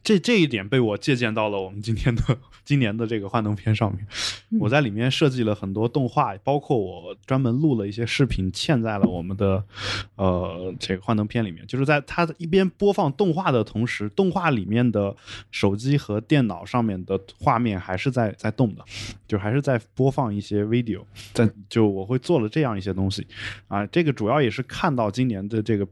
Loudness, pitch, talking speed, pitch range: -23 LUFS, 115 Hz, 310 characters per minute, 105-135 Hz